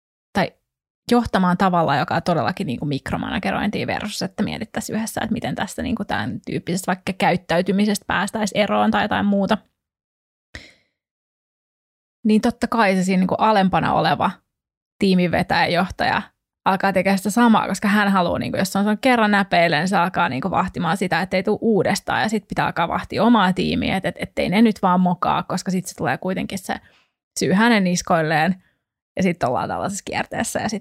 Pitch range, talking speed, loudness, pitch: 180-210 Hz, 165 wpm, -20 LUFS, 195 Hz